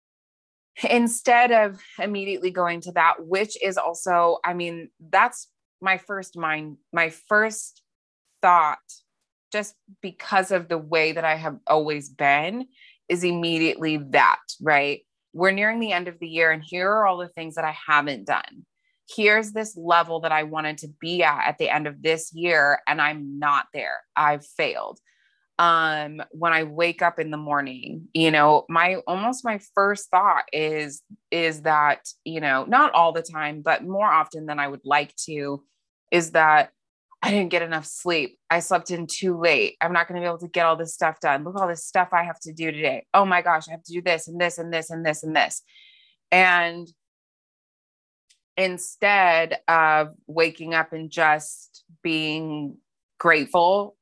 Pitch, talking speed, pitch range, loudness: 165 Hz, 180 wpm, 155-185 Hz, -22 LUFS